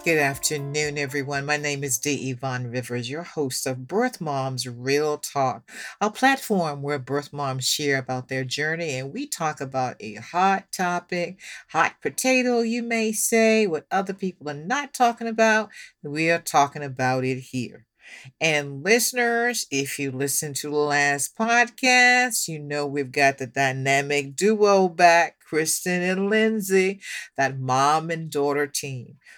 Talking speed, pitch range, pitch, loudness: 155 wpm, 135-195 Hz, 150 Hz, -23 LUFS